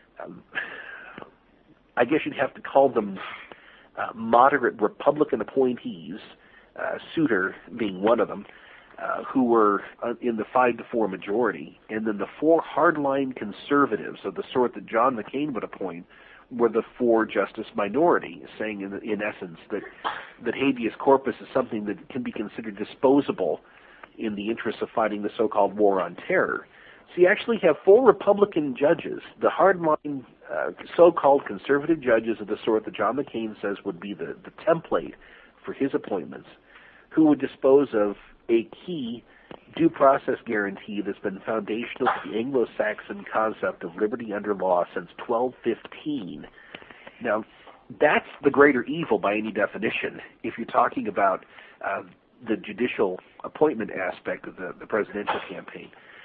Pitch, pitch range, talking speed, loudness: 125 Hz, 110-150 Hz, 155 wpm, -25 LUFS